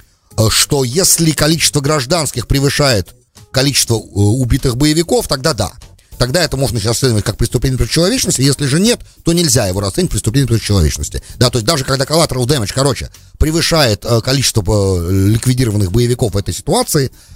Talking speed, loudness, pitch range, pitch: 150 wpm, -13 LUFS, 105-150 Hz, 130 Hz